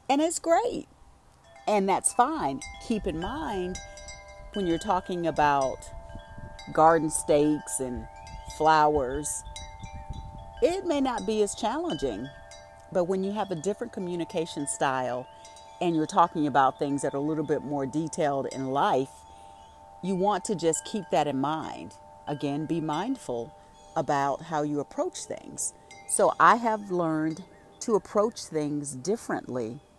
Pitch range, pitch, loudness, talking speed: 130-195 Hz, 155 Hz, -27 LUFS, 140 wpm